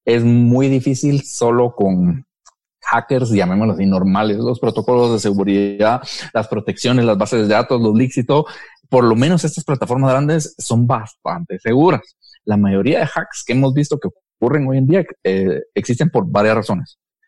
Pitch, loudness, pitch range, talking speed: 120 Hz, -16 LUFS, 110-140 Hz, 170 wpm